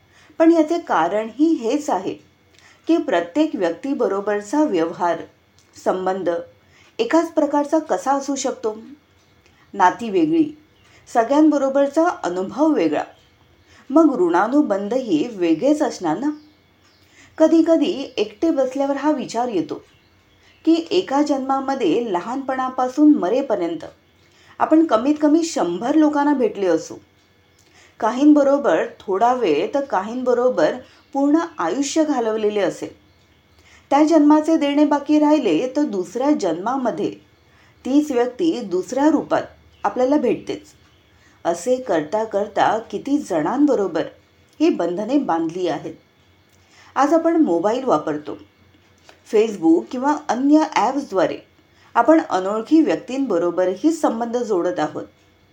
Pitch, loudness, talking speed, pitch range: 275 Hz, -19 LUFS, 95 wpm, 205-310 Hz